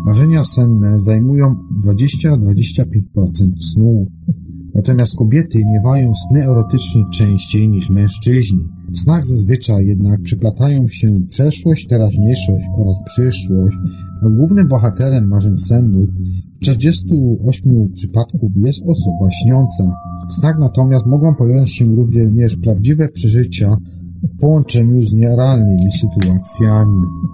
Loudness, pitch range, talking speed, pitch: -13 LUFS, 95-130 Hz, 100 wpm, 110 Hz